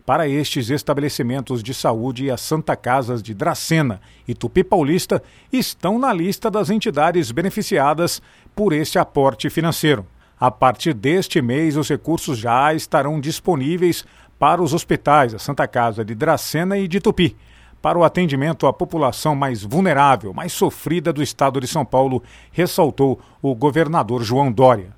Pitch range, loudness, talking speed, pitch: 130-170 Hz, -19 LUFS, 150 wpm, 150 Hz